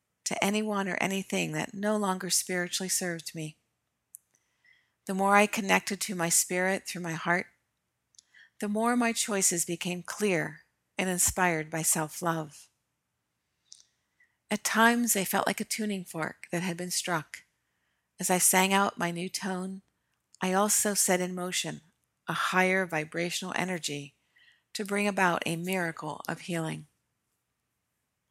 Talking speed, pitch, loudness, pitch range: 140 wpm, 185 Hz, -28 LUFS, 170-200 Hz